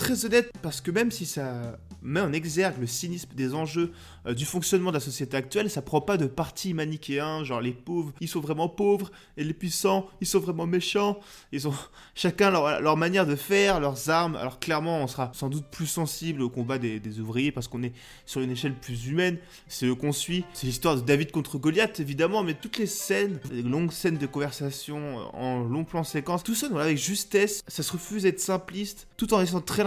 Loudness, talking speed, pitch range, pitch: -28 LUFS, 220 wpm, 140-185 Hz, 160 Hz